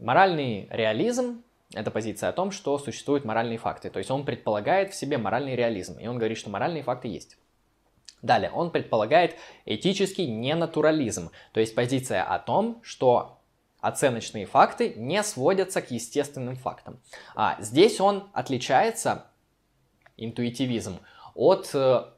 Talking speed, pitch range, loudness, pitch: 135 wpm, 115-185 Hz, -26 LUFS, 135 Hz